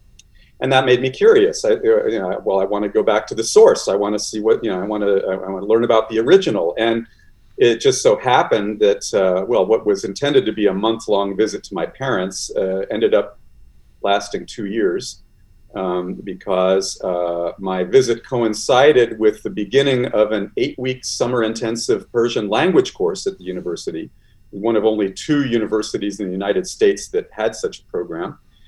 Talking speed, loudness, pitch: 200 wpm, -18 LUFS, 115 Hz